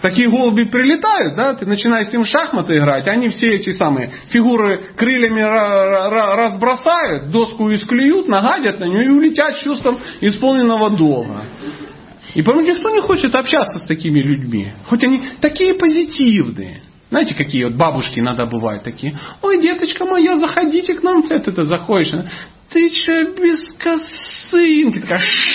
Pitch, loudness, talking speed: 235 Hz, -15 LUFS, 150 wpm